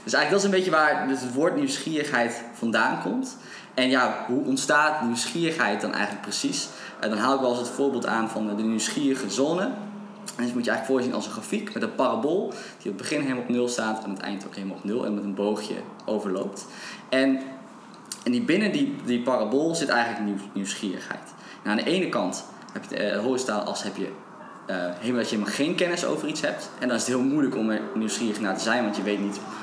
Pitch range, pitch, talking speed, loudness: 110-160 Hz, 125 Hz, 235 wpm, -26 LUFS